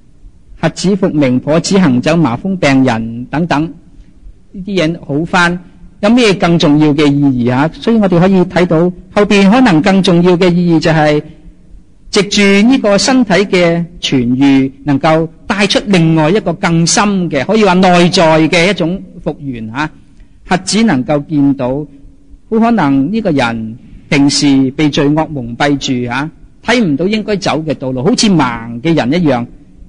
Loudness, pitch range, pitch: -11 LUFS, 140-190 Hz, 165 Hz